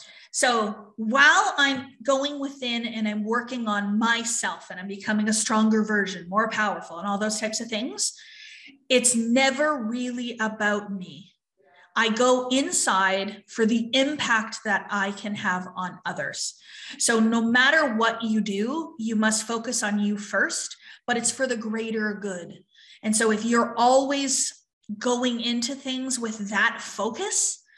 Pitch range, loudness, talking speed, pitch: 210-260 Hz, -24 LUFS, 150 wpm, 230 Hz